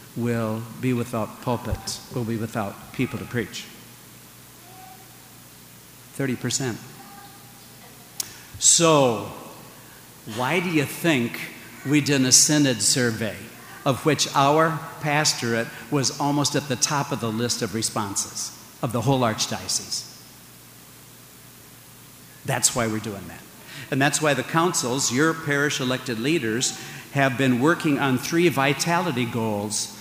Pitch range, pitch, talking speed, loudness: 110-145 Hz, 125 Hz, 120 wpm, -22 LUFS